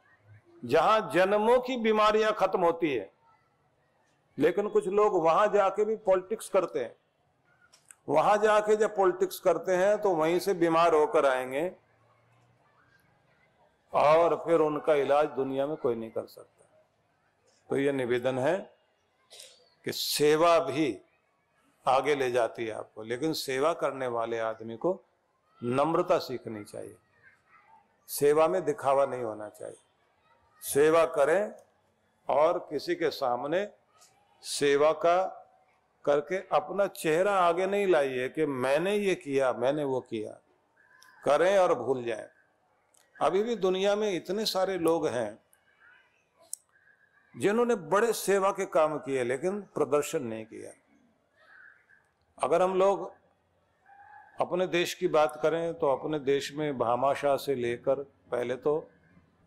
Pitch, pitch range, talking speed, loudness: 165 Hz, 135-195 Hz, 125 wpm, -28 LUFS